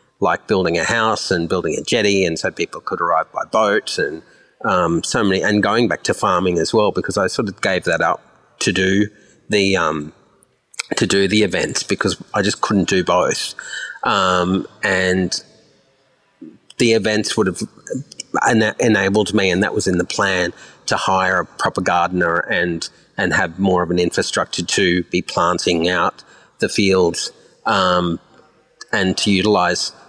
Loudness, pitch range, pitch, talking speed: -18 LUFS, 90-105 Hz, 95 Hz, 170 wpm